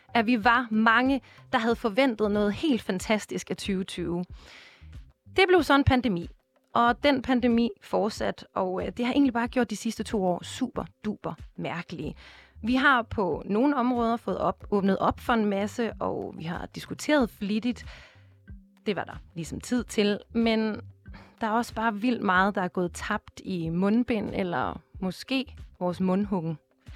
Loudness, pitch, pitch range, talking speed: -27 LUFS, 220 Hz, 185-245 Hz, 165 wpm